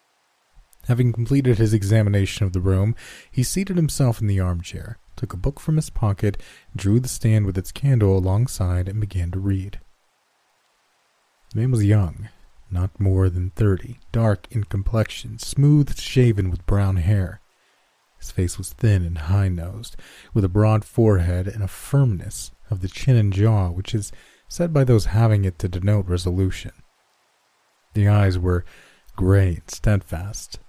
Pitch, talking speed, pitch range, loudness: 105 Hz, 160 wpm, 95-115 Hz, -21 LUFS